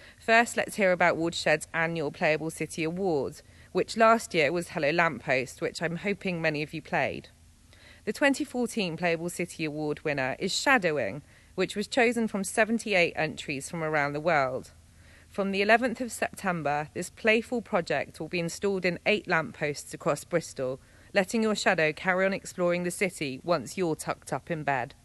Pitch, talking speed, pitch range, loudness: 170 Hz, 170 wpm, 150-200 Hz, -28 LUFS